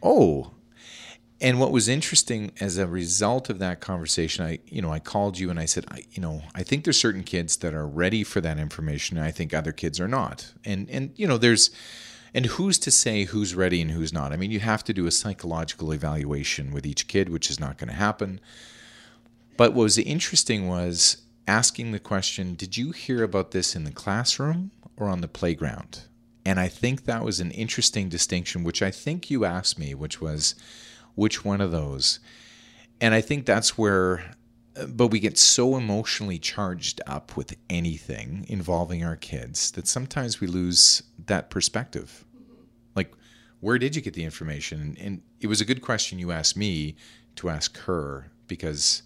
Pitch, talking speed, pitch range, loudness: 100 Hz, 190 wpm, 85-115 Hz, -24 LUFS